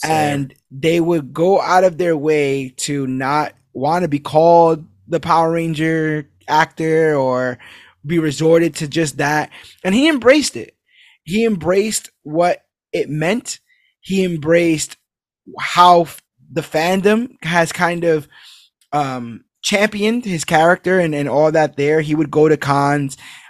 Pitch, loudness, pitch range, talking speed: 160 Hz, -16 LUFS, 150-180 Hz, 140 wpm